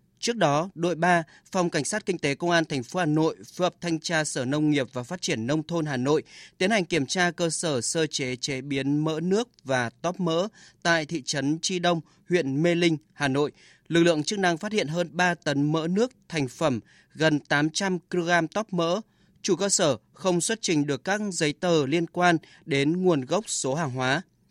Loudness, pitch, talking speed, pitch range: -26 LUFS, 165 Hz, 220 wpm, 145-180 Hz